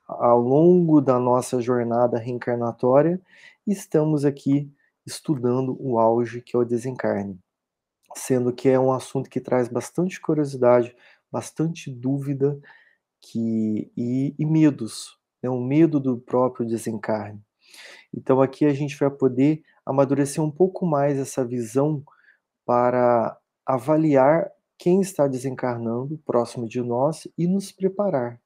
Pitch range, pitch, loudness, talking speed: 120-150 Hz, 130 Hz, -22 LUFS, 125 wpm